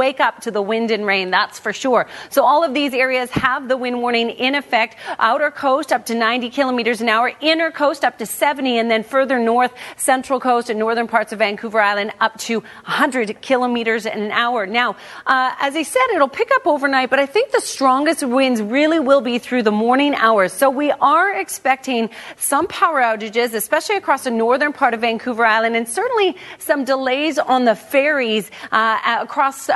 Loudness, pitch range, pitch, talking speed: -17 LUFS, 225-280 Hz, 250 Hz, 200 wpm